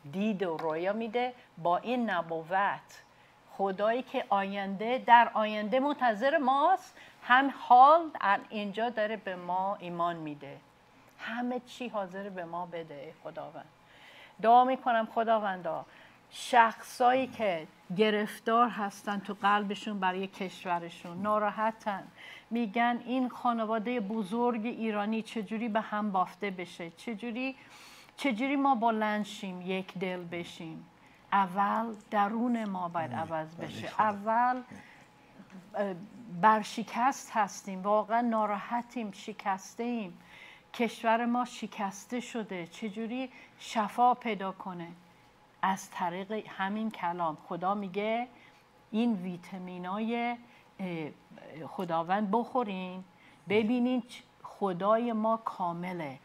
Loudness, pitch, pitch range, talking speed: -31 LUFS, 210 Hz, 190-235 Hz, 100 wpm